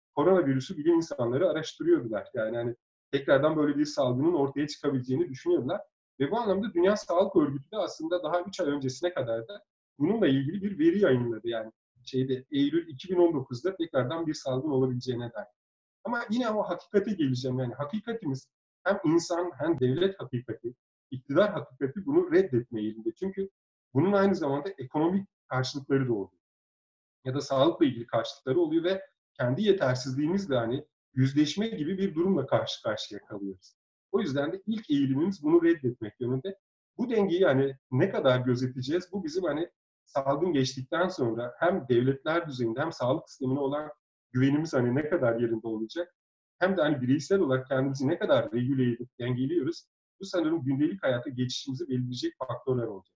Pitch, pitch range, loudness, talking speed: 145 Hz, 130-185 Hz, -29 LUFS, 150 wpm